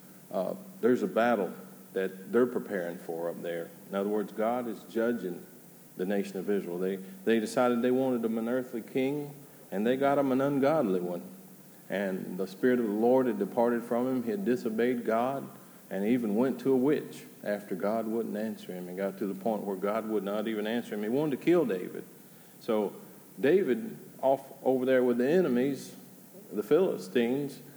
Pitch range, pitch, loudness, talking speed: 100-130 Hz, 115 Hz, -30 LUFS, 190 wpm